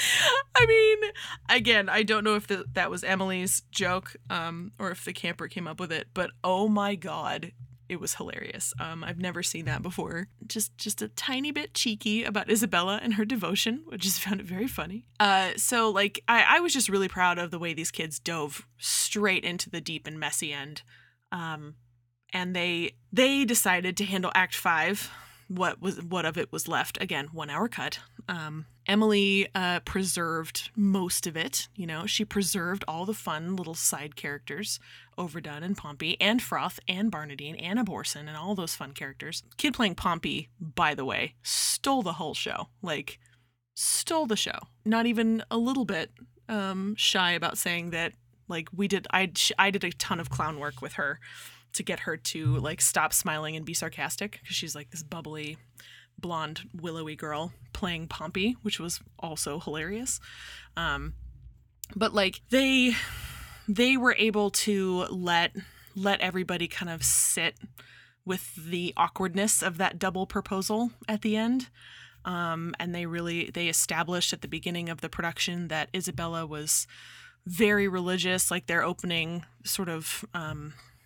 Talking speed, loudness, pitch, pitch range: 170 wpm, -28 LUFS, 180 Hz, 165-205 Hz